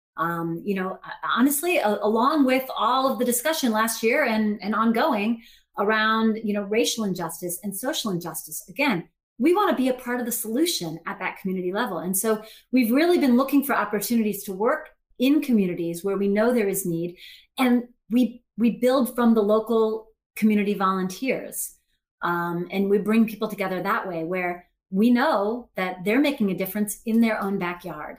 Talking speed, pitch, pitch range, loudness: 180 wpm, 220 Hz, 190-245 Hz, -24 LUFS